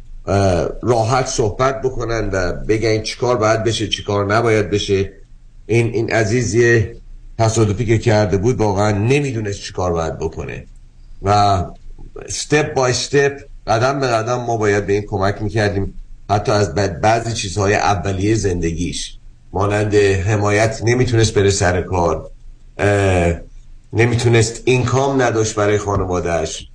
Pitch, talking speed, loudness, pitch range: 105 Hz, 120 wpm, -17 LUFS, 100-115 Hz